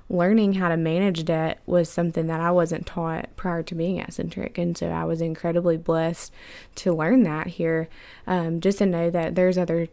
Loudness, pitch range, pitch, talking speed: -24 LUFS, 165-180 Hz, 170 Hz, 195 wpm